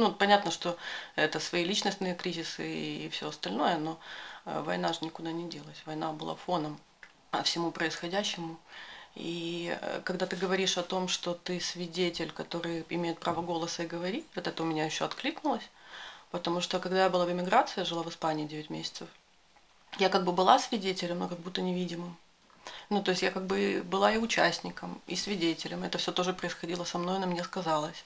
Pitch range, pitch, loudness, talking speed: 165-185 Hz, 175 Hz, -32 LUFS, 180 wpm